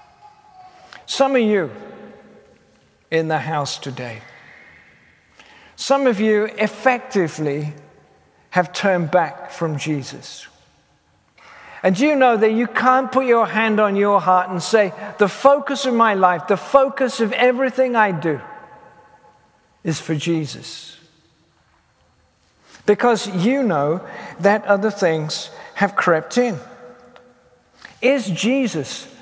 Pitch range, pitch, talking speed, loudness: 160-245 Hz, 200 Hz, 115 wpm, -18 LUFS